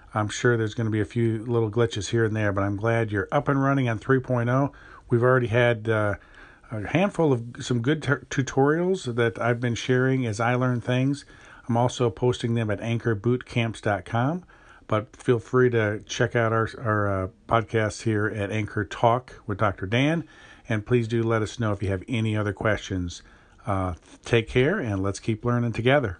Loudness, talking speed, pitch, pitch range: -25 LUFS, 190 wpm, 115 Hz, 105-125 Hz